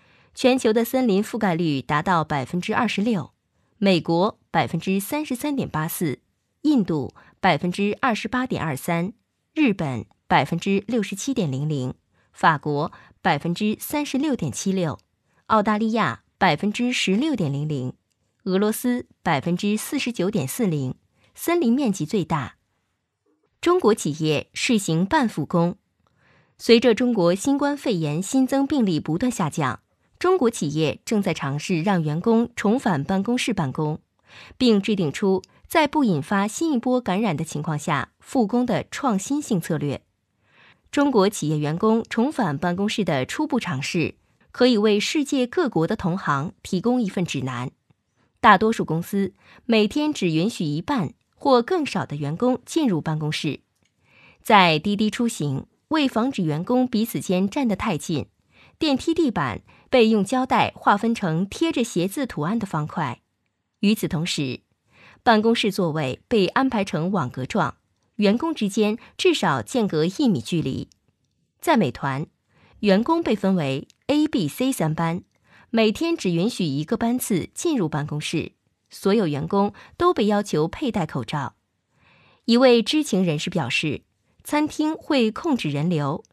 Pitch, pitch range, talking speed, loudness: 195 Hz, 155-240 Hz, 230 characters per minute, -22 LUFS